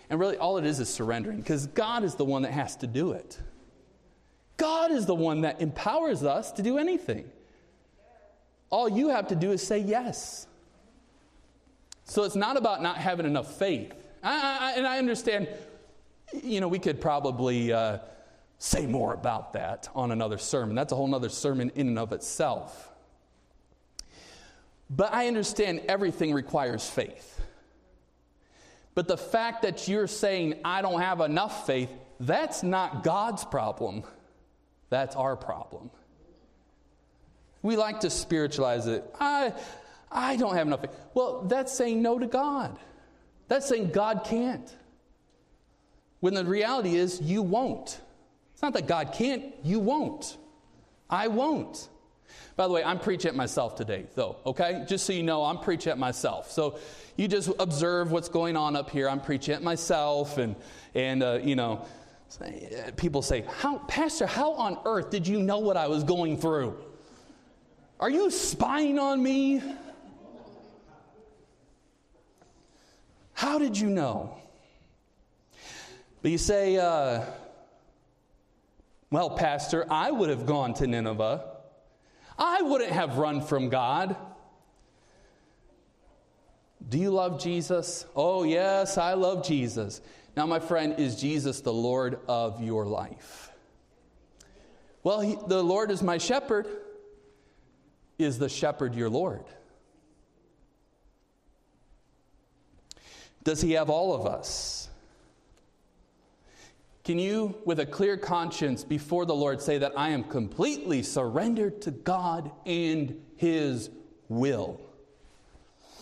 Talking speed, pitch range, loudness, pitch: 145 wpm, 140-210 Hz, -29 LUFS, 170 Hz